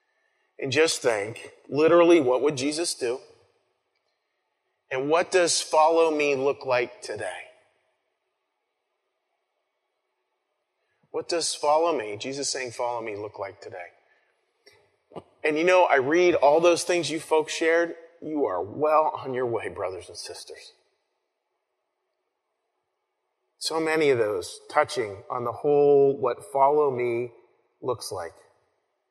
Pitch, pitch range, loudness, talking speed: 155 Hz, 140-170 Hz, -24 LUFS, 125 wpm